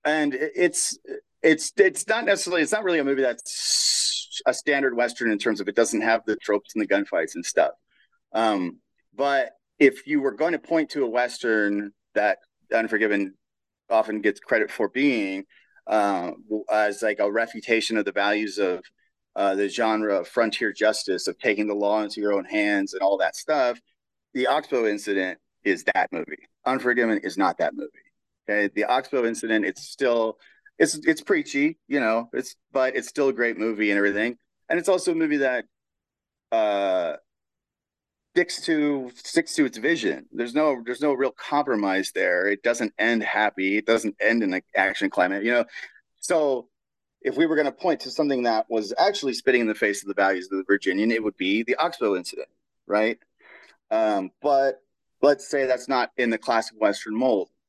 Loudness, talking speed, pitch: -24 LUFS, 185 wpm, 125 Hz